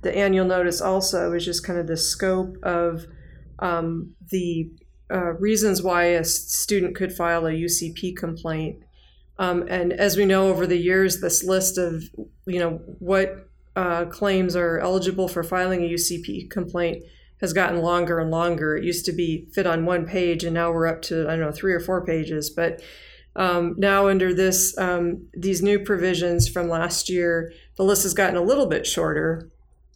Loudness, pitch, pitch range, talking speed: -22 LUFS, 175 Hz, 170-185 Hz, 180 wpm